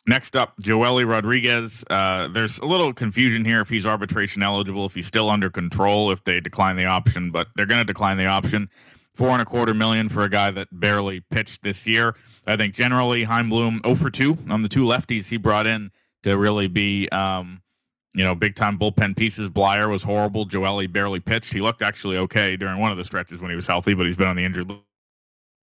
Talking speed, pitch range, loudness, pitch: 220 wpm, 95-115 Hz, -21 LUFS, 105 Hz